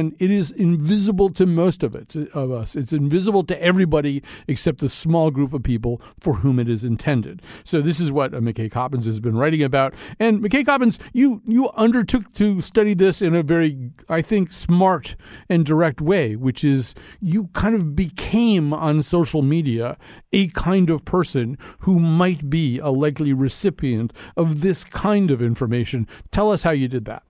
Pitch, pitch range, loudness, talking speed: 160 Hz, 135-190 Hz, -20 LUFS, 180 wpm